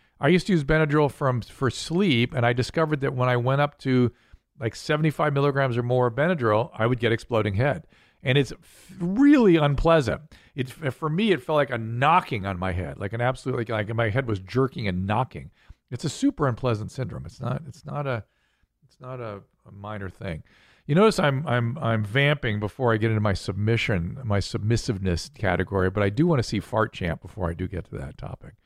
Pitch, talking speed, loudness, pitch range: 125 Hz, 215 wpm, -24 LUFS, 105-145 Hz